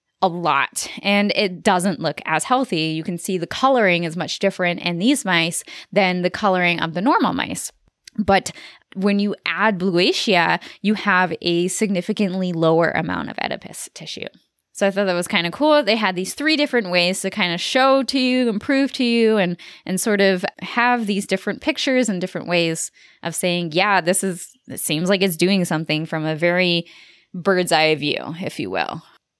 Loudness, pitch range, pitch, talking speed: -19 LUFS, 175-215 Hz, 190 Hz, 195 wpm